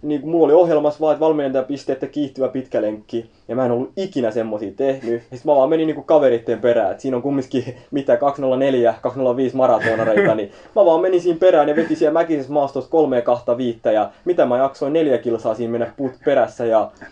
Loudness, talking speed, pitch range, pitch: -18 LUFS, 205 wpm, 120-150 Hz, 135 Hz